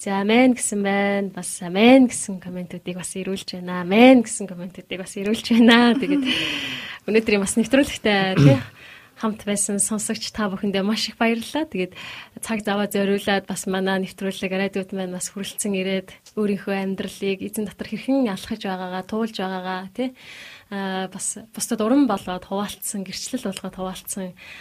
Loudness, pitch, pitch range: -22 LUFS, 200 Hz, 190-220 Hz